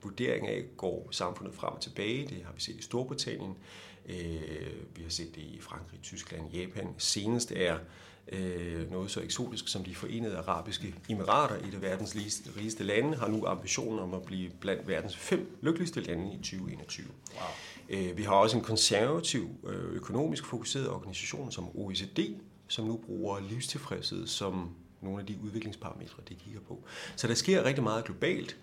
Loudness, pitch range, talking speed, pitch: -34 LUFS, 90-115 Hz, 160 wpm, 100 Hz